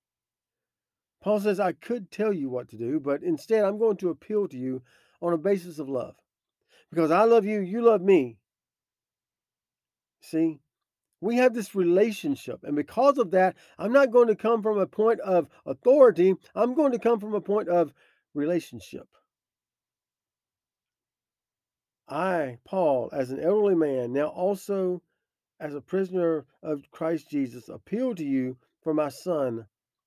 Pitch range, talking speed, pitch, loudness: 150-215 Hz, 155 wpm, 180 Hz, -26 LUFS